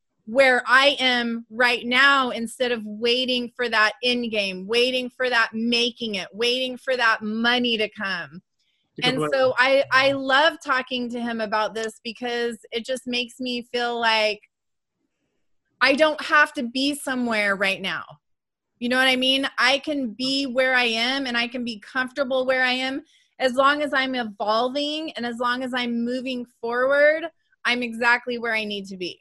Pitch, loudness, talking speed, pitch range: 245 Hz, -22 LUFS, 175 wpm, 230-260 Hz